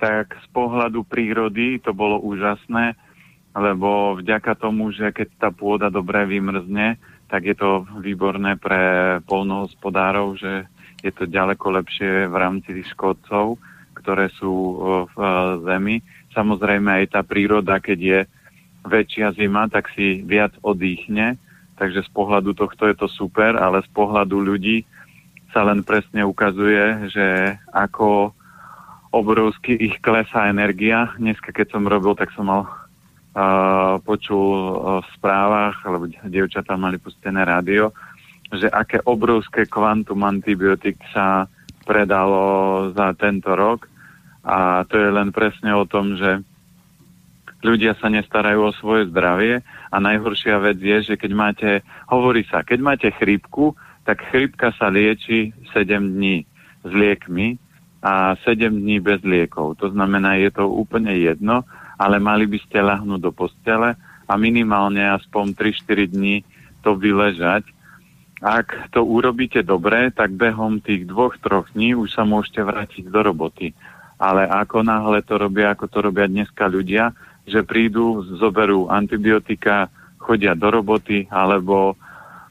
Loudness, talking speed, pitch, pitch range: -19 LUFS, 135 wpm, 105 Hz, 95-110 Hz